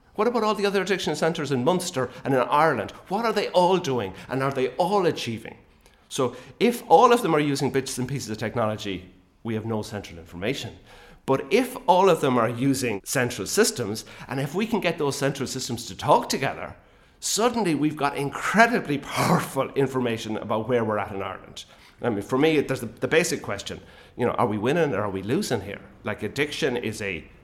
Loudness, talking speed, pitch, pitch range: -24 LUFS, 205 wpm, 130 Hz, 105-155 Hz